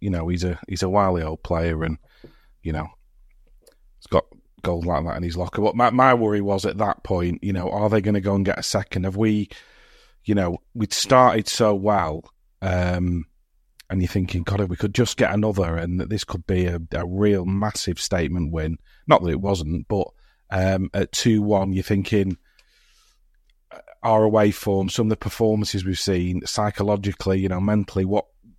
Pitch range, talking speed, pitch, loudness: 90-105 Hz, 195 wpm, 95 Hz, -22 LUFS